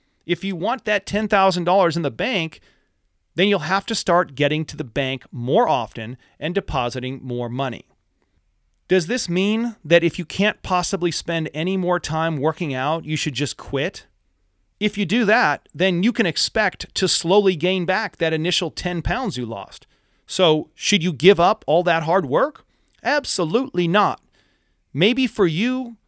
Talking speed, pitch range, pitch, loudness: 170 wpm, 155-195 Hz, 175 Hz, -20 LUFS